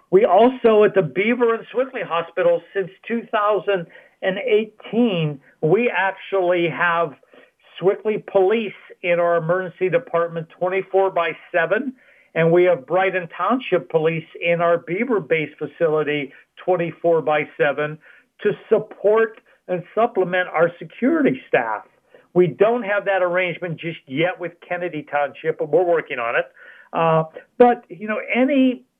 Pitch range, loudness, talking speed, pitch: 170-210 Hz, -20 LUFS, 130 wpm, 180 Hz